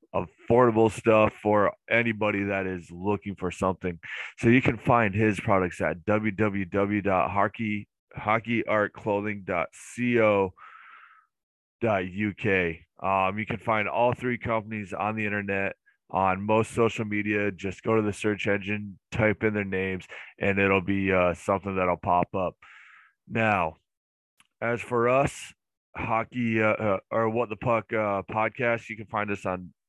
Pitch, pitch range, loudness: 105 Hz, 95-110 Hz, -26 LUFS